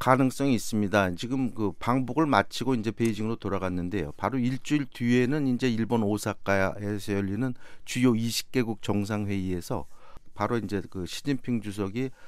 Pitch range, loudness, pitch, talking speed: 100-125 Hz, -28 LUFS, 115 Hz, 345 characters per minute